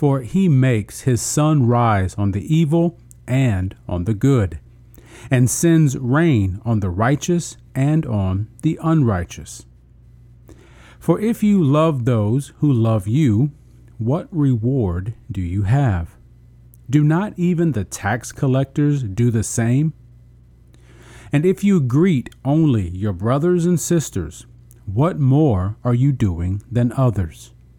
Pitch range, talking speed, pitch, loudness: 110-150 Hz, 130 wpm, 120 Hz, -18 LUFS